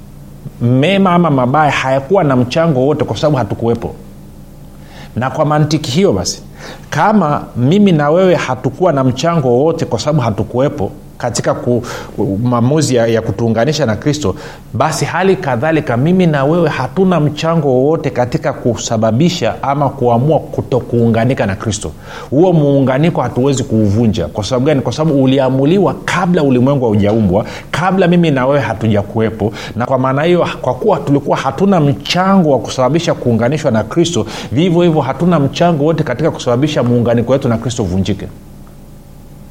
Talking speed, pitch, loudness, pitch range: 135 wpm, 130 Hz, -13 LUFS, 115-155 Hz